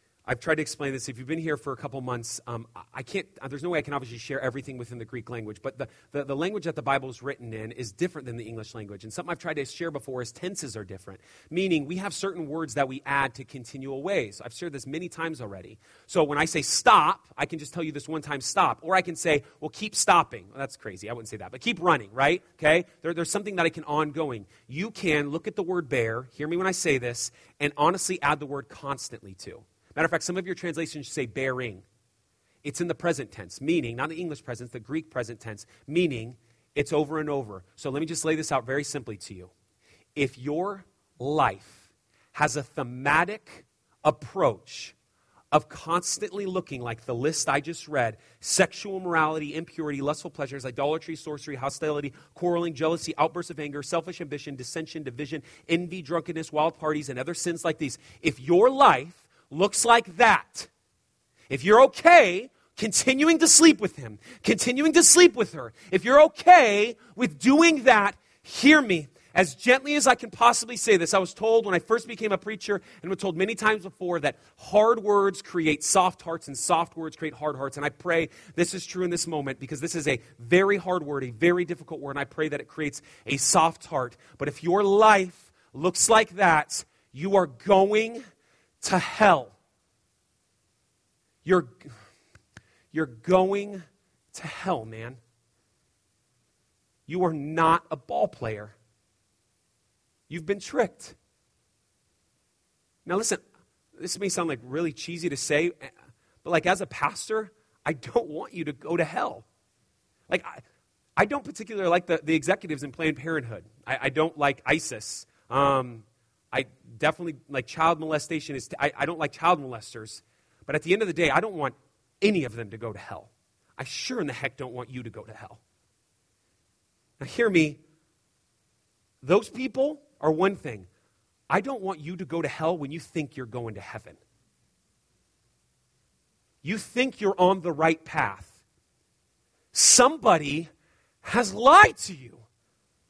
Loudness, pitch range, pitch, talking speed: -25 LUFS, 130-180 Hz, 155 Hz, 190 wpm